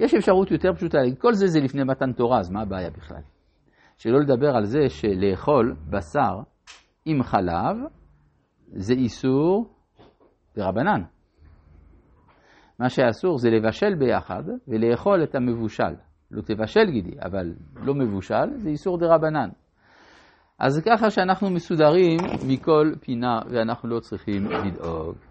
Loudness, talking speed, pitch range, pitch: -23 LUFS, 125 wpm, 100-155 Hz, 125 Hz